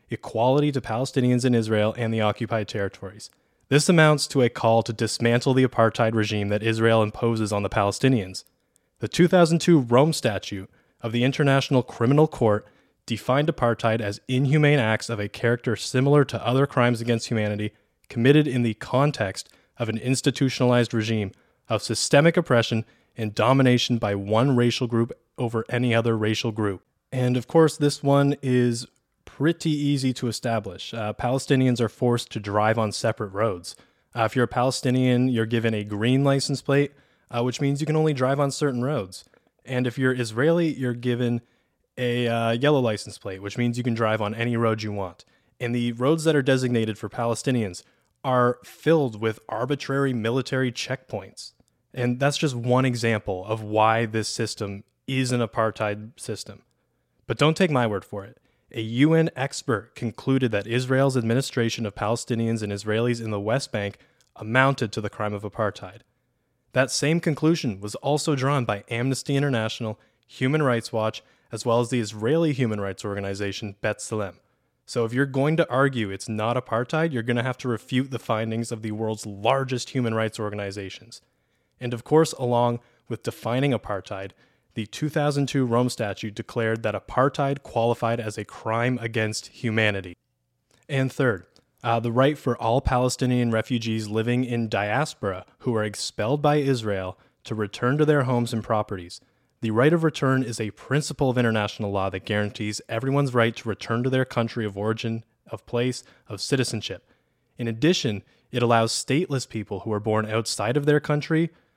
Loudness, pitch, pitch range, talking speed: -24 LUFS, 120 Hz, 110-130 Hz, 170 wpm